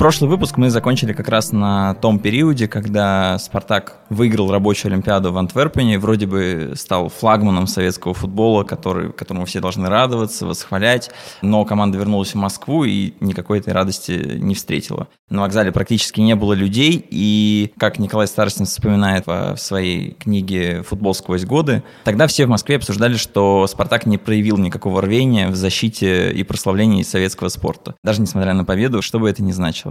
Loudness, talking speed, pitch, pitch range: -17 LUFS, 165 wpm, 105 Hz, 95-110 Hz